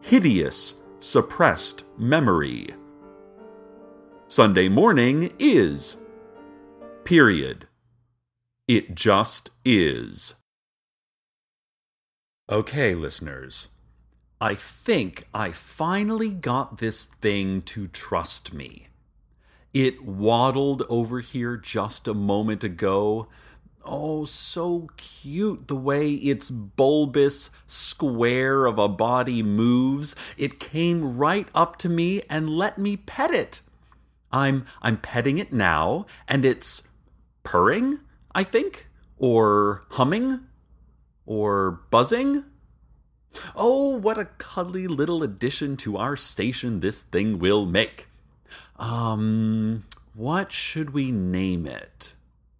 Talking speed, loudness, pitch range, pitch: 100 wpm, -23 LUFS, 105-160 Hz, 125 Hz